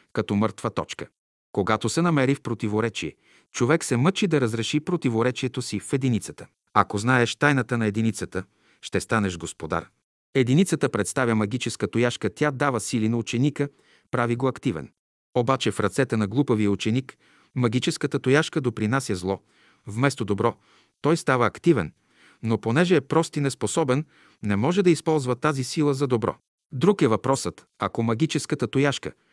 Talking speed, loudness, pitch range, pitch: 145 wpm, -24 LUFS, 110-145 Hz, 125 Hz